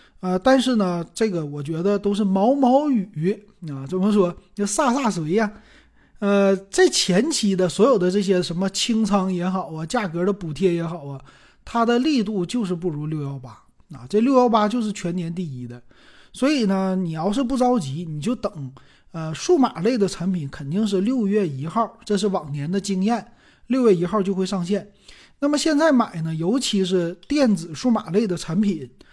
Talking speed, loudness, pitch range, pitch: 265 characters per minute, -21 LUFS, 175-225 Hz, 195 Hz